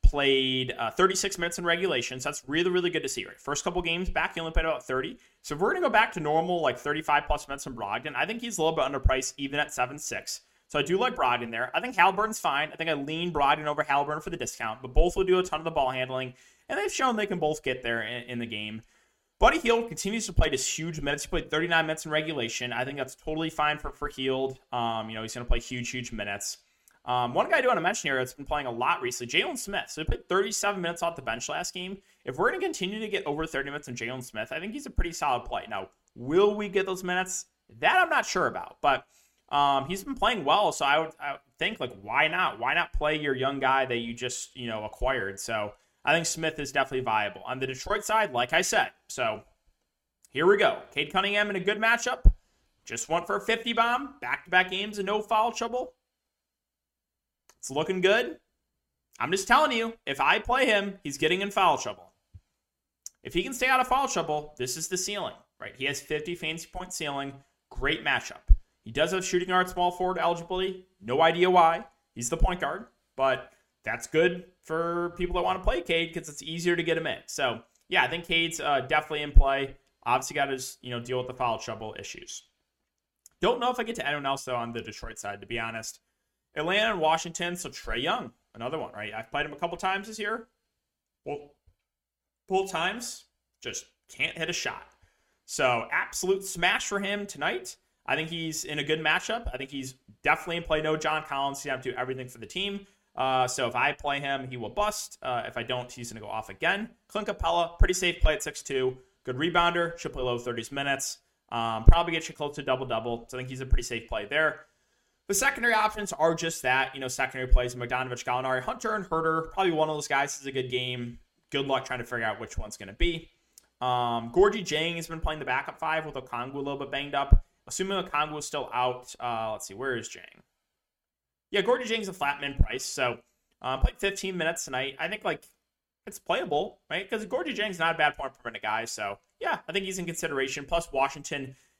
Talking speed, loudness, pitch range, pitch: 235 wpm, -28 LUFS, 125-180 Hz, 150 Hz